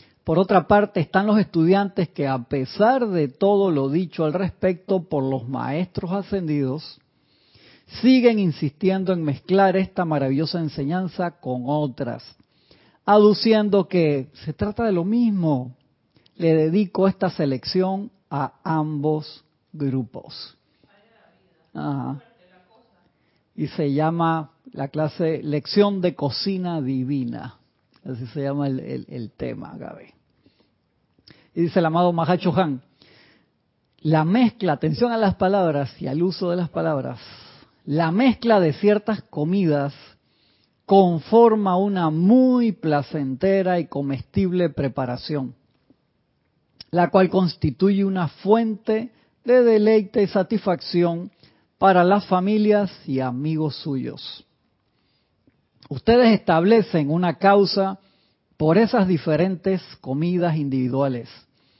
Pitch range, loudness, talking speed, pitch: 145-195 Hz, -21 LUFS, 110 wpm, 175 Hz